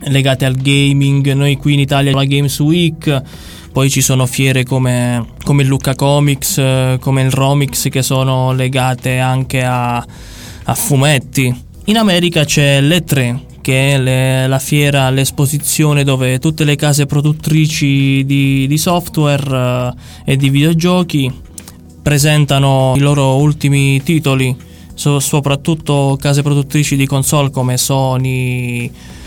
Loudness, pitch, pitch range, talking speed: -13 LUFS, 135 Hz, 130-145 Hz, 130 wpm